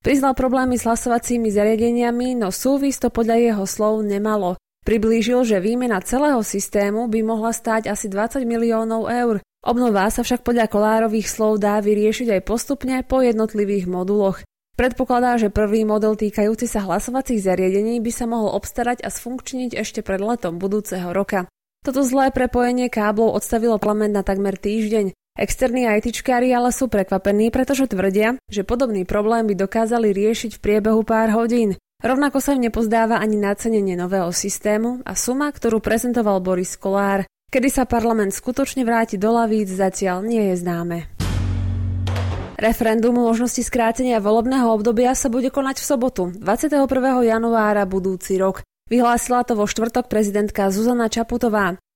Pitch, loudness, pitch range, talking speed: 225 Hz, -19 LUFS, 205-245 Hz, 150 wpm